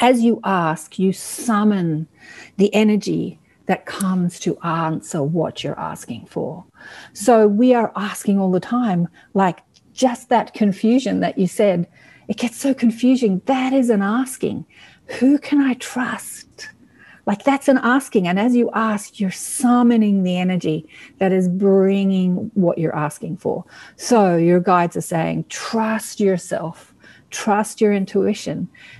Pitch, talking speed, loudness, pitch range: 210 Hz, 145 wpm, -19 LUFS, 185-245 Hz